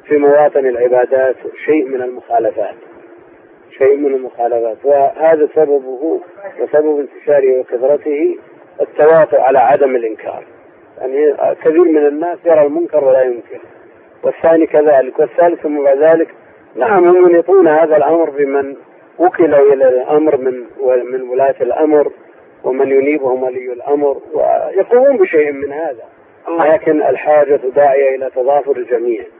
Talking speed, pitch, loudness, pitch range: 120 wpm, 150 Hz, -12 LUFS, 135-190 Hz